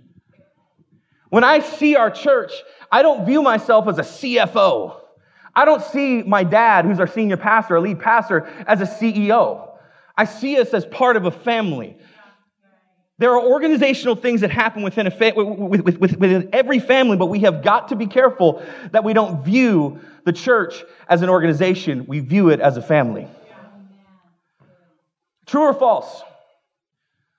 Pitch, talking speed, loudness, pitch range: 210 Hz, 160 wpm, -17 LUFS, 180-245 Hz